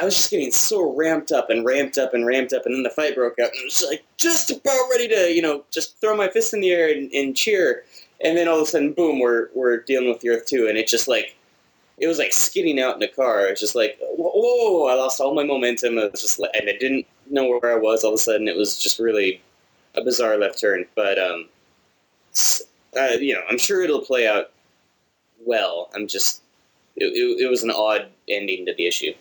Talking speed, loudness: 255 wpm, -20 LUFS